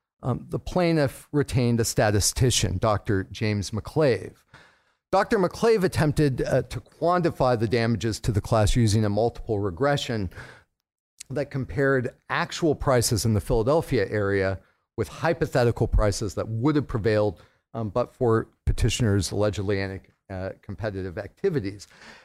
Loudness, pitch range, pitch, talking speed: -25 LUFS, 105-140 Hz, 115 Hz, 130 wpm